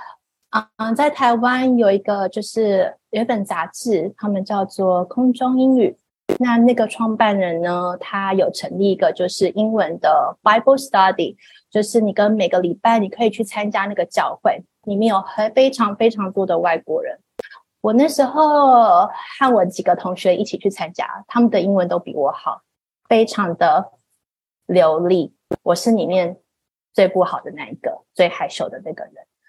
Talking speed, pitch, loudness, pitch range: 265 characters per minute, 210 Hz, -18 LUFS, 190-235 Hz